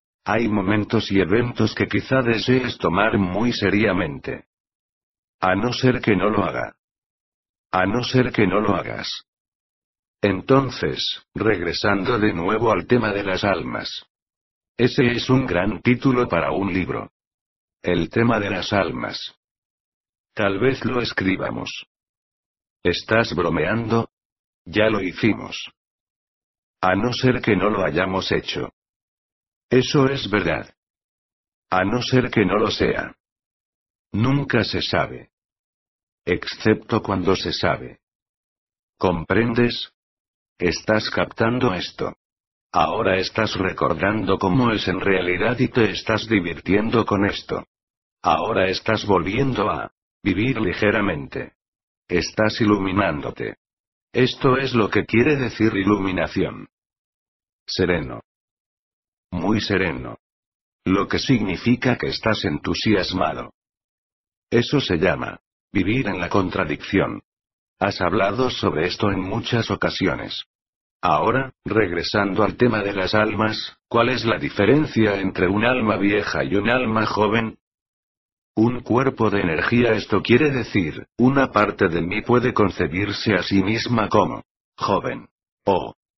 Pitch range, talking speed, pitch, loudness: 95-115 Hz, 120 wpm, 105 Hz, -21 LUFS